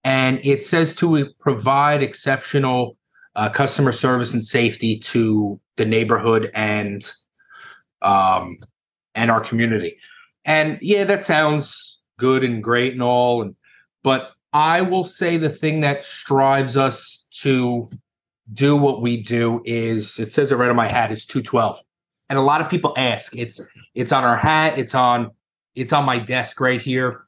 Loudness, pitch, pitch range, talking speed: -19 LUFS, 130 Hz, 115-145 Hz, 155 wpm